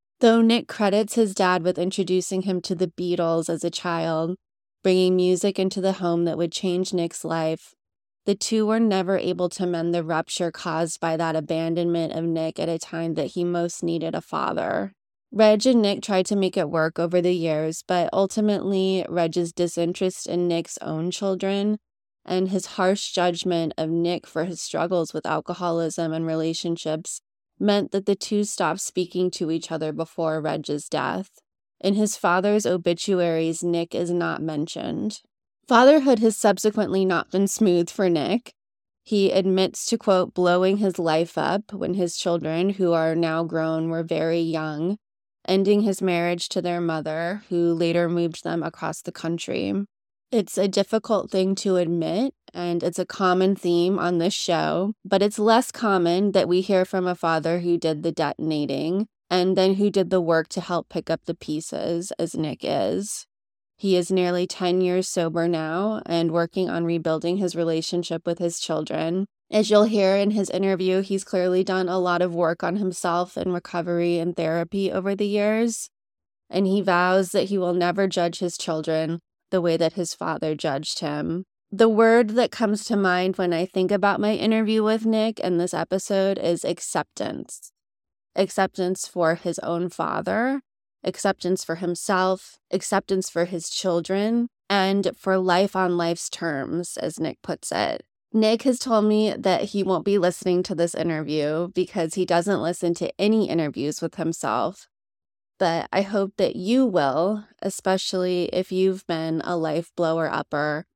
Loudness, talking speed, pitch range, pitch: -23 LUFS, 170 wpm, 170-195 Hz, 180 Hz